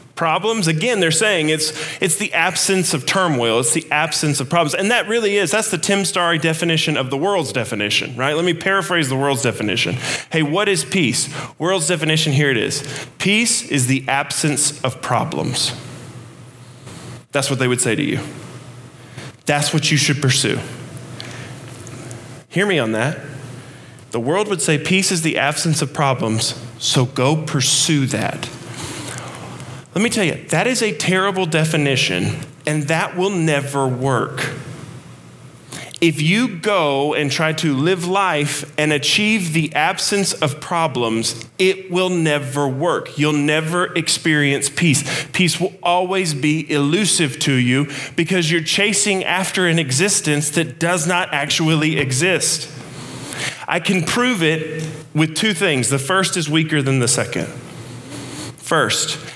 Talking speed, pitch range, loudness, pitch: 150 wpm, 135-175 Hz, -17 LUFS, 150 Hz